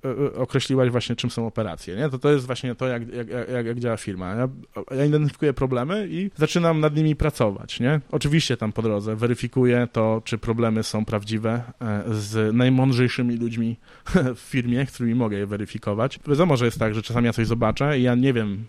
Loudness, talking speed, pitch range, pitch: -23 LUFS, 195 wpm, 115-135 Hz, 120 Hz